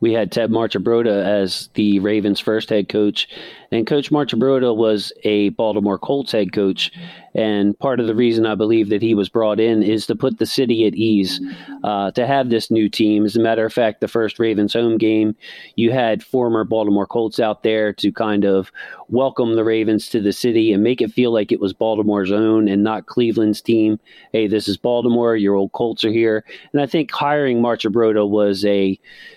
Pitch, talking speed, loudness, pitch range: 110 Hz, 200 wpm, -18 LUFS, 105-115 Hz